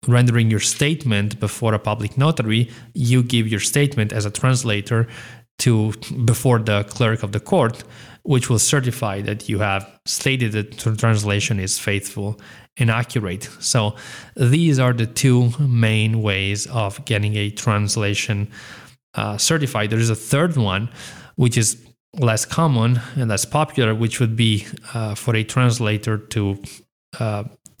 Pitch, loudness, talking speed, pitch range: 115 Hz, -20 LUFS, 150 wpm, 105-125 Hz